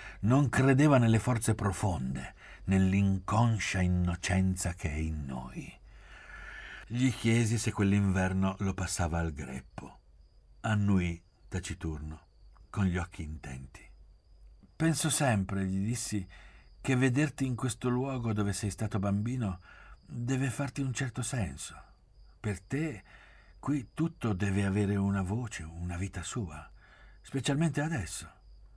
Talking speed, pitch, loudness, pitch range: 115 wpm, 100 Hz, -31 LUFS, 90-120 Hz